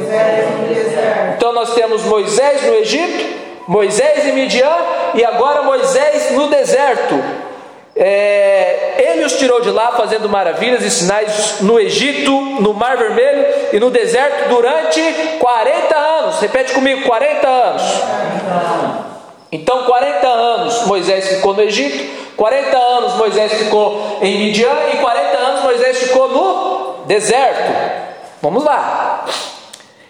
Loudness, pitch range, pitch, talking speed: -13 LUFS, 210-275 Hz, 235 Hz, 120 wpm